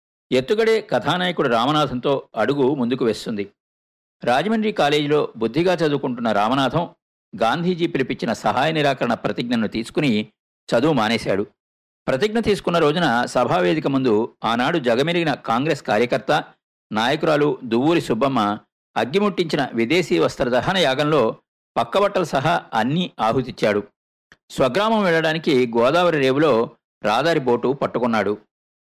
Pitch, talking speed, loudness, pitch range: 150 Hz, 95 wpm, -20 LUFS, 120-180 Hz